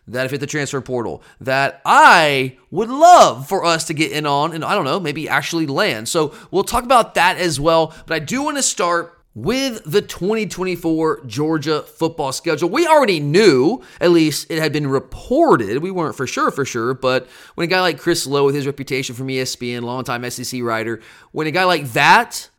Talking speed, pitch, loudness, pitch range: 205 wpm, 155 Hz, -17 LUFS, 135-180 Hz